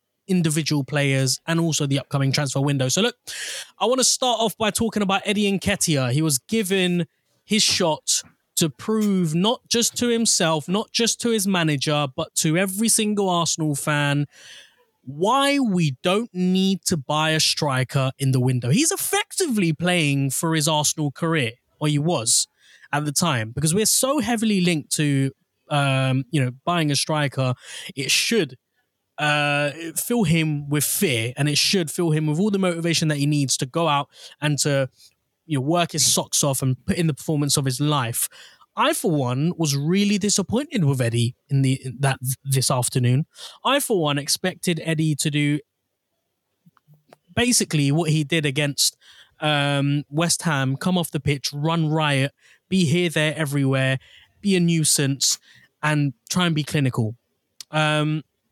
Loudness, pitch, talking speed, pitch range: -21 LUFS, 155 Hz, 170 wpm, 140-180 Hz